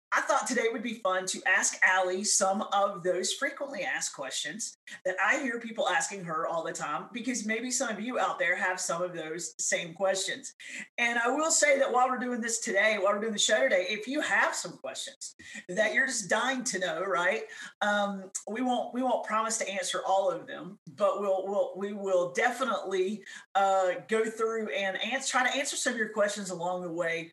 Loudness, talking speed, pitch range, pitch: -29 LUFS, 215 wpm, 190-250 Hz, 210 Hz